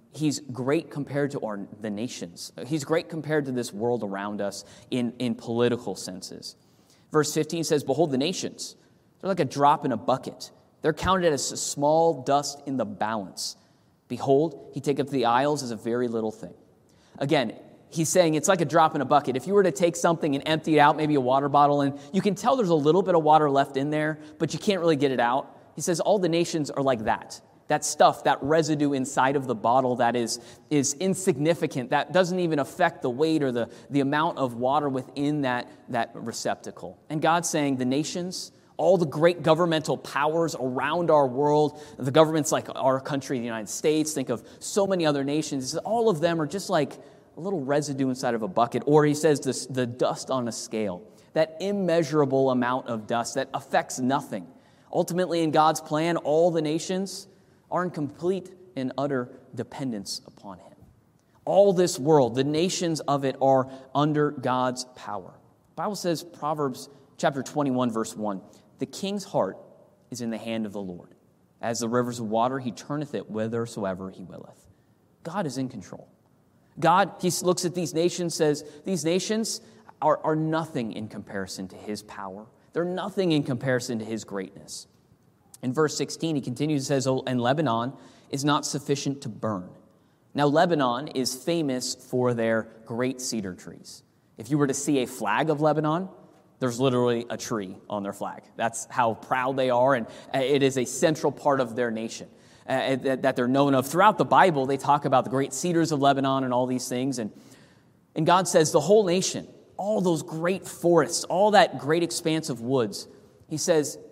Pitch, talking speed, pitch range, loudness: 140 Hz, 190 wpm, 125-160 Hz, -25 LUFS